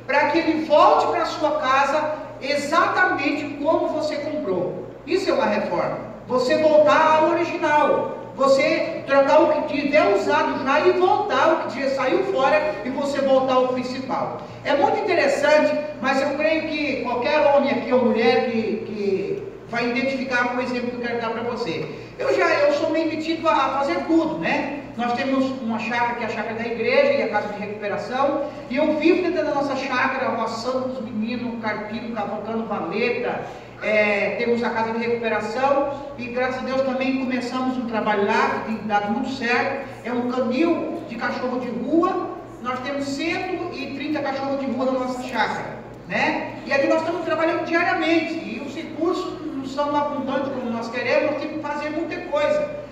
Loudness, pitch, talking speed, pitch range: -22 LUFS, 275 Hz, 185 wpm, 245-305 Hz